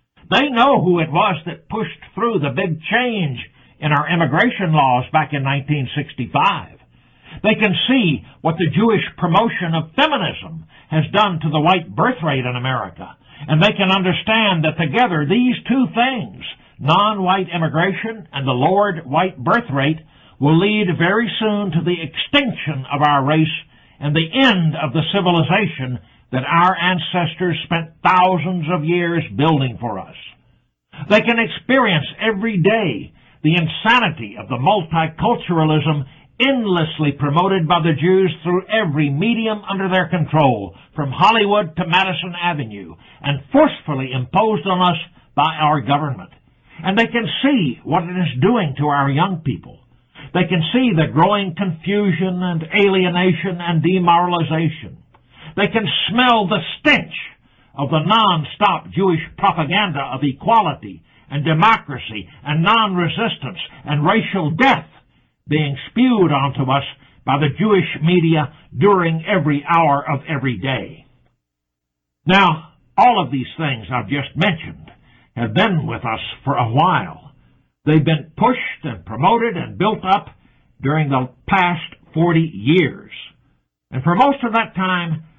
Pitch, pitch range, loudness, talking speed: 165 Hz, 145-195 Hz, -17 LUFS, 140 wpm